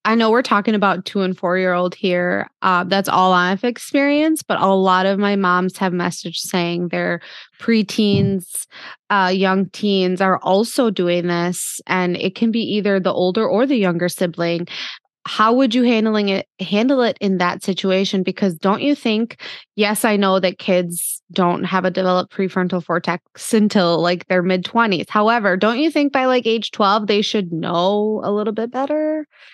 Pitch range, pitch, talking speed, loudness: 180-220 Hz, 195 Hz, 180 wpm, -18 LUFS